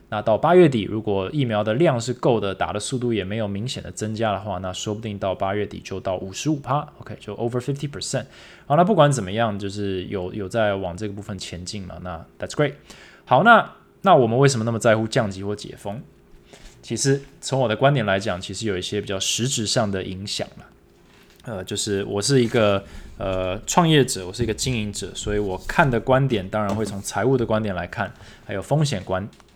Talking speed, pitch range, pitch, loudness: 350 characters per minute, 100-125 Hz, 105 Hz, -22 LUFS